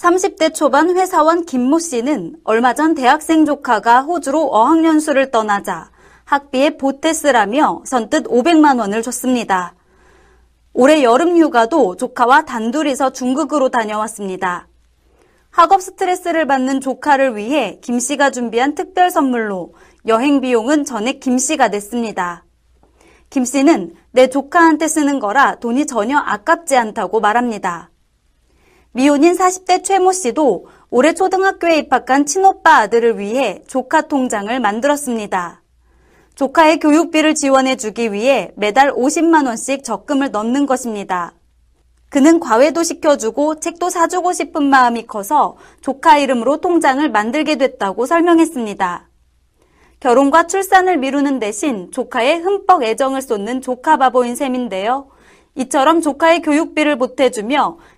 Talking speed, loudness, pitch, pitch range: 295 characters per minute, -15 LUFS, 275 Hz, 235-315 Hz